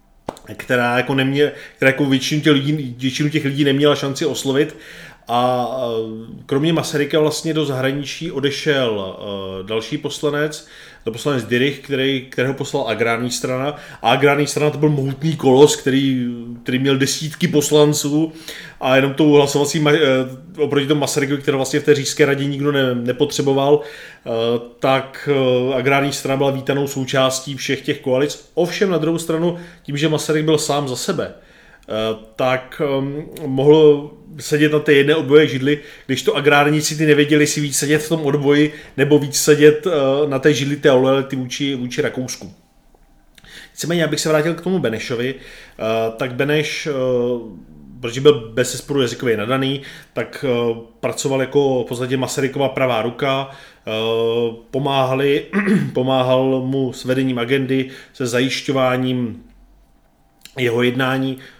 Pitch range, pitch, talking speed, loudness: 130-150 Hz, 140 Hz, 145 wpm, -18 LUFS